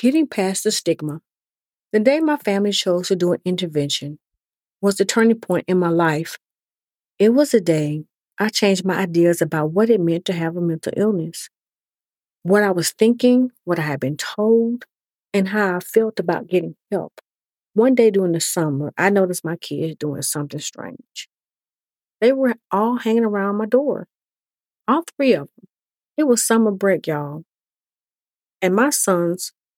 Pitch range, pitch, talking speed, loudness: 165-225 Hz, 195 Hz, 170 wpm, -19 LUFS